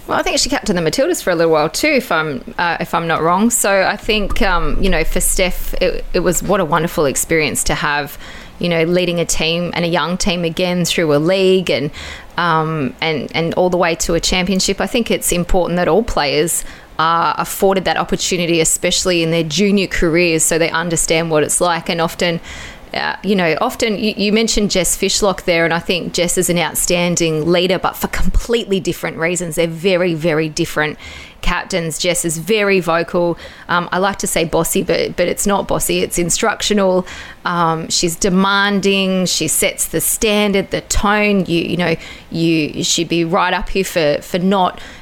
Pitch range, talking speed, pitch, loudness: 165-195 Hz, 200 wpm, 175 Hz, -15 LUFS